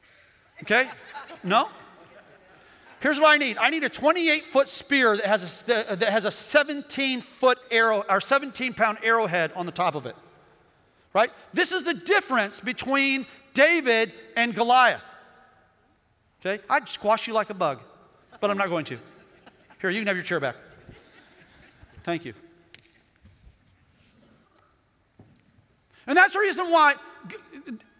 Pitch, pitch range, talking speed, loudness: 235 Hz, 205-285 Hz, 125 wpm, -23 LUFS